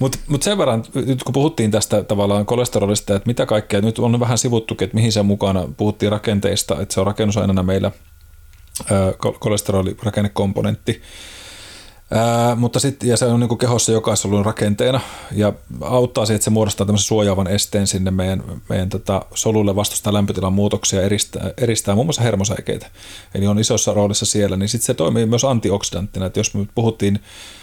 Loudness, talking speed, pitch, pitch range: -18 LUFS, 165 wpm, 105 Hz, 100-115 Hz